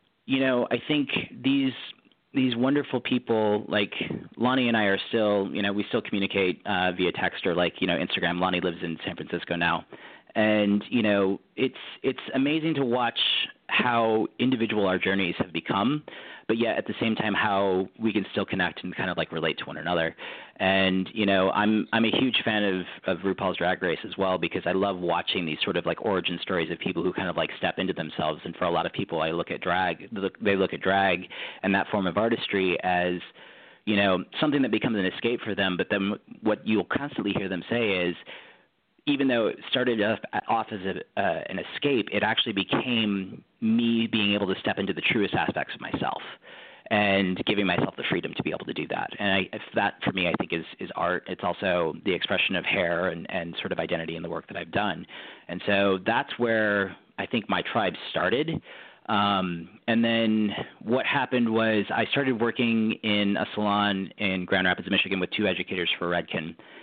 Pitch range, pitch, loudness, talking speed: 95-115 Hz, 100 Hz, -26 LUFS, 210 wpm